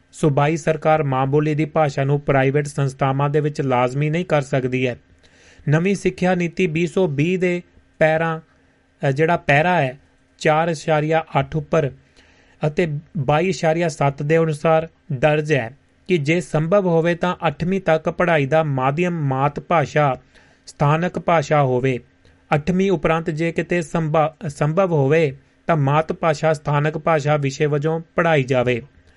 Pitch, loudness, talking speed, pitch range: 155 Hz, -19 LUFS, 130 wpm, 145-170 Hz